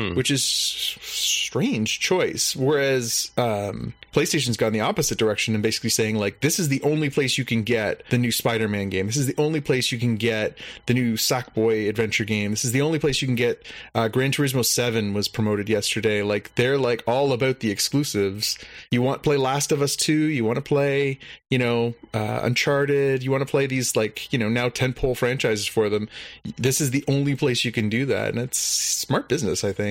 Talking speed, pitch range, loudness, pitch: 215 wpm, 110-140 Hz, -22 LUFS, 120 Hz